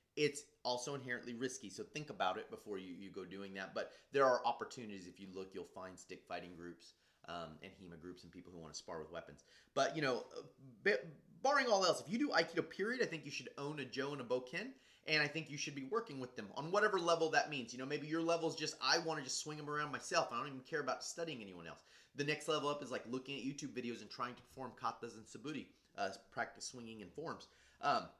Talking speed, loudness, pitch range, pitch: 255 wpm, -40 LUFS, 110-150 Hz, 135 Hz